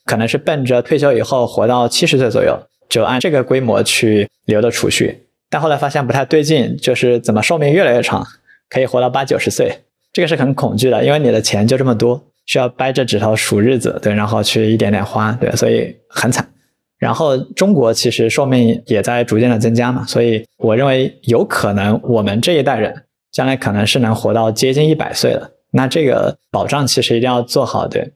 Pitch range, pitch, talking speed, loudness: 110-135 Hz, 125 Hz, 320 characters per minute, -14 LUFS